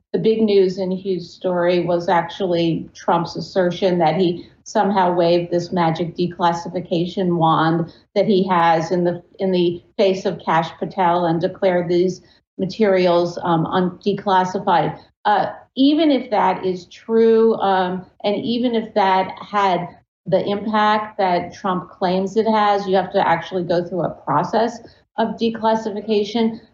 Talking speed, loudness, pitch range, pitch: 150 wpm, -19 LUFS, 175-205 Hz, 185 Hz